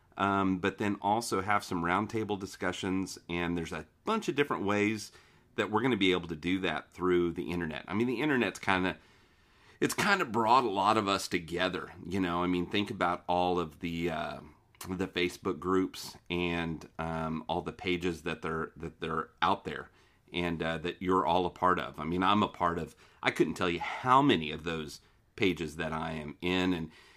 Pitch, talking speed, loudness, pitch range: 90 Hz, 200 wpm, -31 LUFS, 85-95 Hz